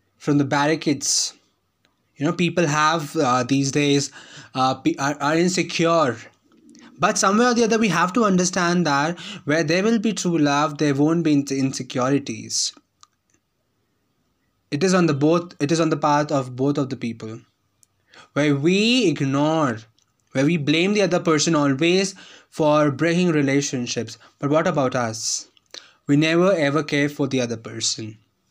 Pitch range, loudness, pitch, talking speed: 135-170 Hz, -20 LUFS, 150 Hz, 160 wpm